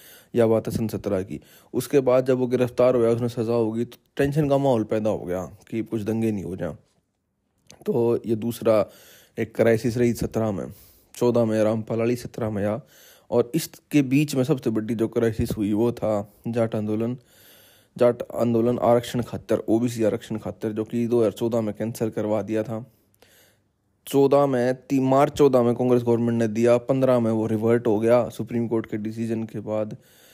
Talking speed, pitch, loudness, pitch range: 190 wpm, 115 Hz, -23 LUFS, 110-120 Hz